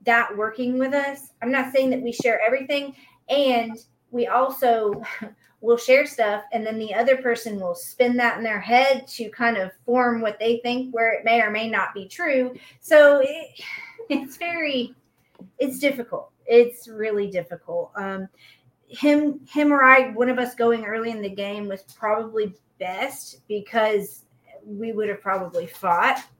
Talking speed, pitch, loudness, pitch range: 170 wpm, 235 Hz, -22 LUFS, 210-260 Hz